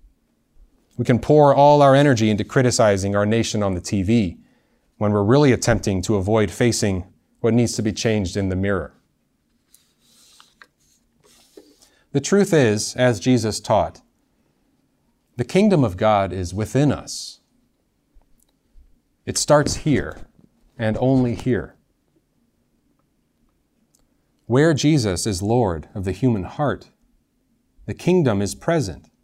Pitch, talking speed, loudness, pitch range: 110 Hz, 120 wpm, -19 LUFS, 100-130 Hz